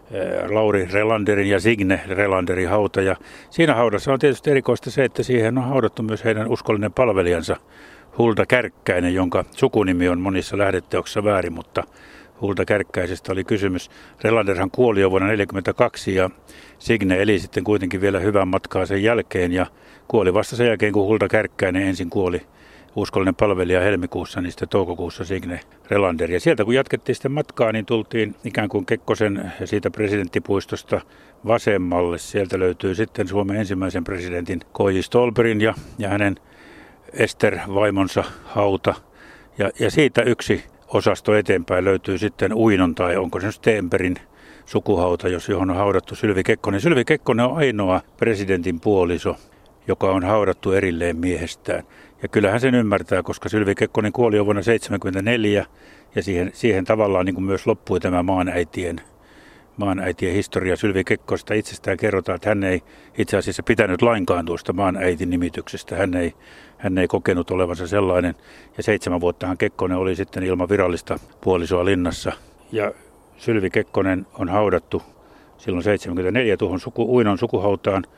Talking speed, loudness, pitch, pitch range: 145 wpm, -21 LUFS, 100 Hz, 95-110 Hz